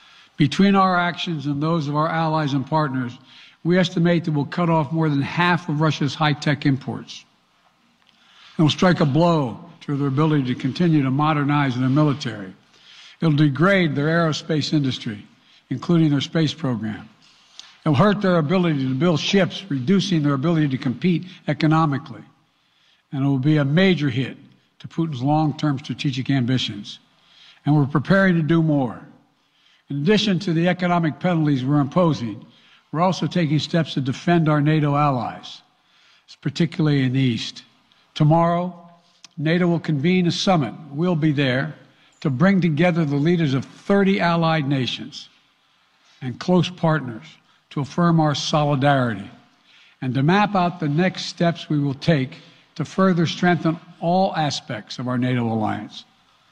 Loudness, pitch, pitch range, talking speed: -20 LUFS, 155 Hz, 140-175 Hz, 155 wpm